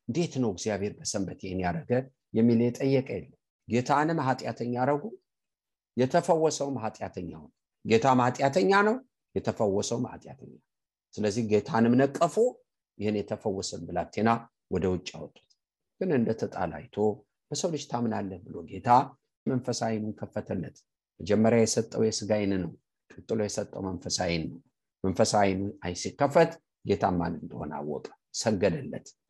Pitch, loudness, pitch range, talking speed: 115 Hz, -28 LUFS, 105-135 Hz, 105 wpm